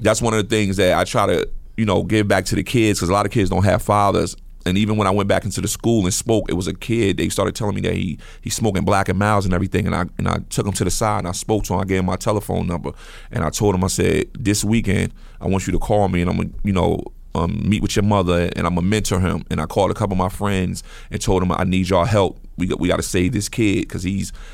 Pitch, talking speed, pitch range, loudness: 100 Hz, 310 wpm, 90-105 Hz, -19 LUFS